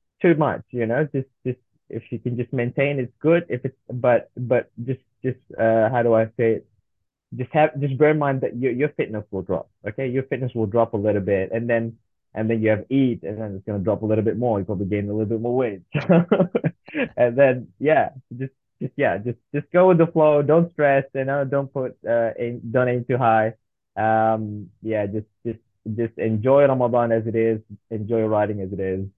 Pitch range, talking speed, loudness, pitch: 110-135 Hz, 225 wpm, -22 LUFS, 120 Hz